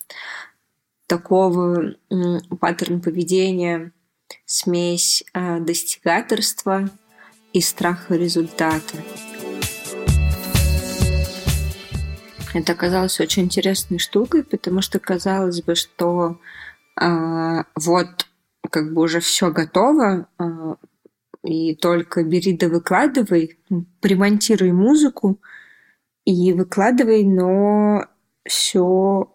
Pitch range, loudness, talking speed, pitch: 165-190 Hz, -19 LUFS, 75 wpm, 175 Hz